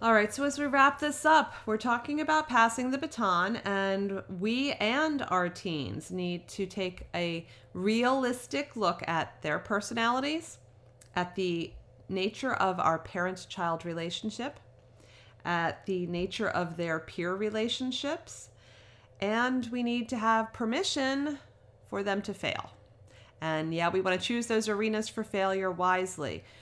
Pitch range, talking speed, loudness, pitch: 170-240 Hz, 145 wpm, -30 LUFS, 195 Hz